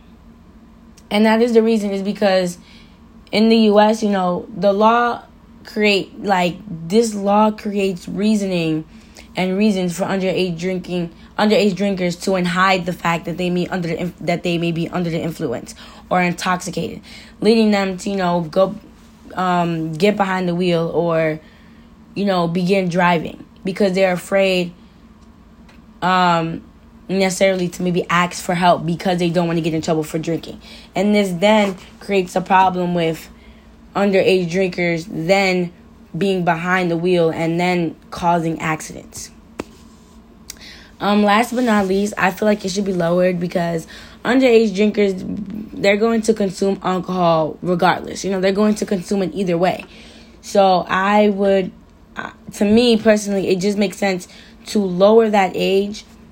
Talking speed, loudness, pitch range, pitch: 155 wpm, -17 LUFS, 175-205 Hz, 190 Hz